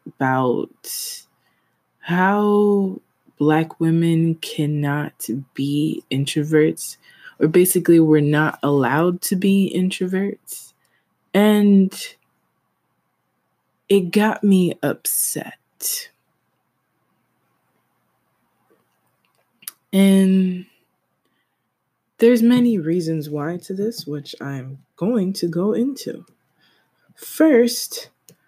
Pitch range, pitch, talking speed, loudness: 155-210 Hz, 185 Hz, 70 wpm, -19 LUFS